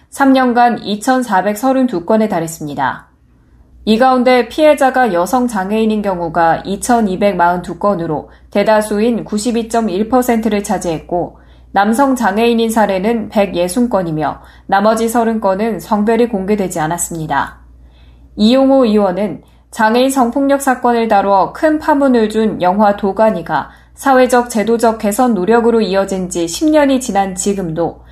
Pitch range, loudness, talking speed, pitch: 185-240 Hz, -13 LUFS, 255 characters per minute, 215 Hz